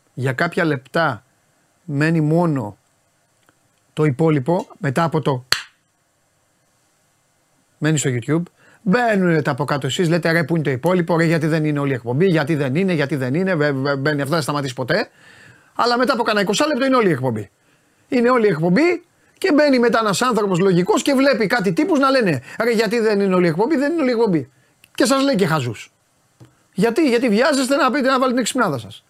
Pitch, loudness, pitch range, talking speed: 170 Hz, -18 LUFS, 145-235 Hz, 200 wpm